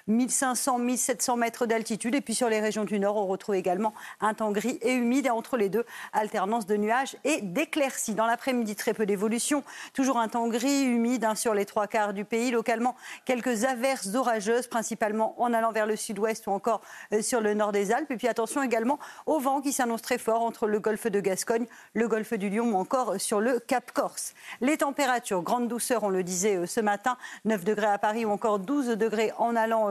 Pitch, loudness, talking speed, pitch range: 230 Hz, -27 LUFS, 210 wpm, 215-250 Hz